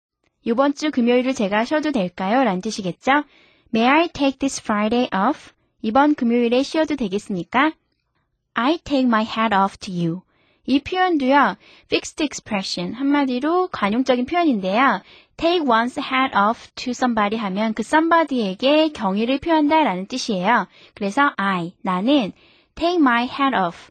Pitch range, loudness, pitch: 210-285 Hz, -20 LUFS, 250 Hz